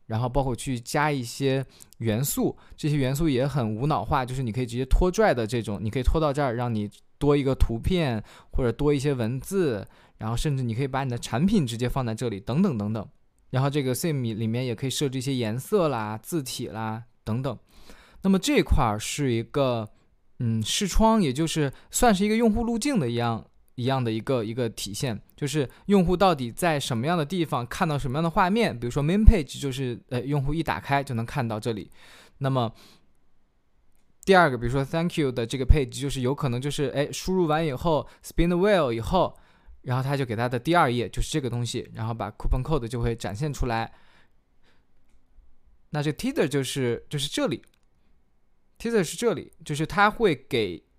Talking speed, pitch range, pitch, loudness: 340 characters per minute, 115-155 Hz, 130 Hz, -26 LUFS